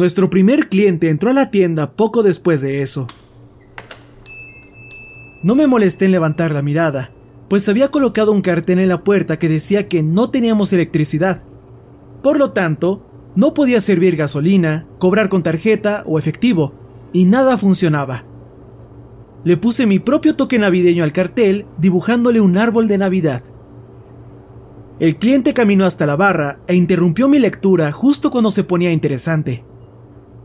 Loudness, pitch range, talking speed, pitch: -14 LUFS, 150-210 Hz, 150 wpm, 180 Hz